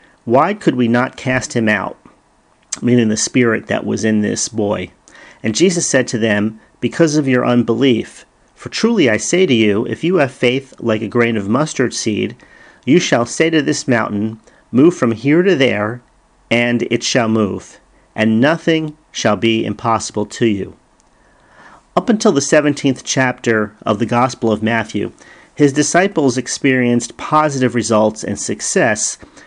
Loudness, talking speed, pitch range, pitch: -15 LUFS, 160 wpm, 110-140 Hz, 120 Hz